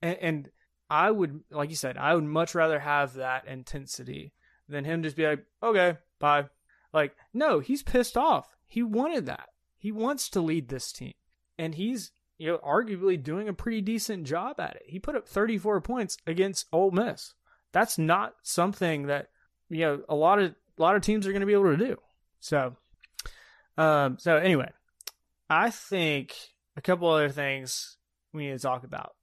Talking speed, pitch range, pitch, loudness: 185 wpm, 150-205 Hz, 170 Hz, -28 LUFS